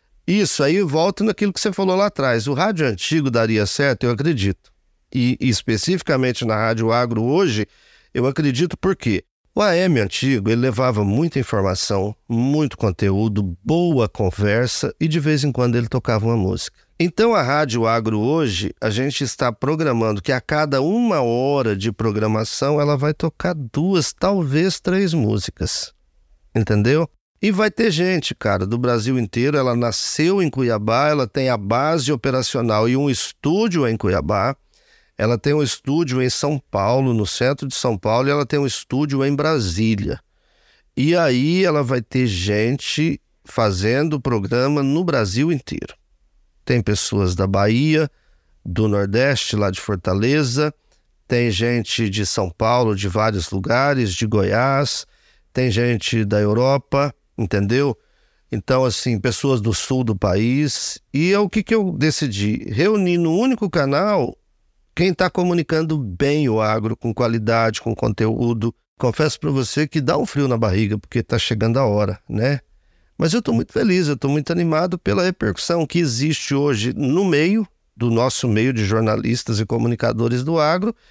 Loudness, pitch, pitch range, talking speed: -19 LUFS, 125 Hz, 110-150 Hz, 160 wpm